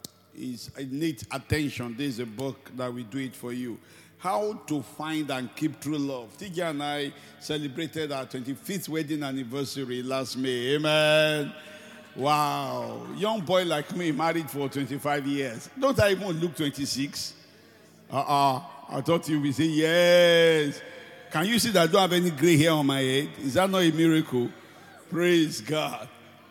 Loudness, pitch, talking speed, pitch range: -26 LUFS, 150 Hz, 165 wpm, 135-165 Hz